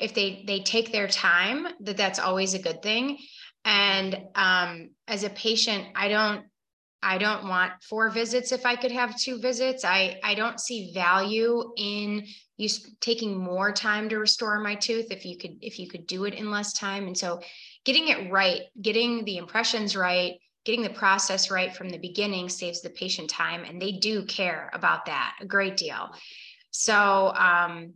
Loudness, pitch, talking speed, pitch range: -25 LUFS, 205 Hz, 185 wpm, 185-225 Hz